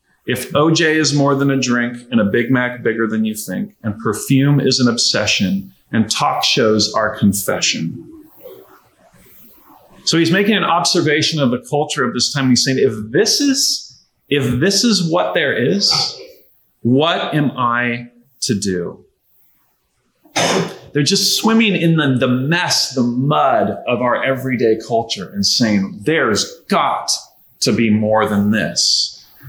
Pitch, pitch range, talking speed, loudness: 135 Hz, 120-170 Hz, 150 wpm, -15 LUFS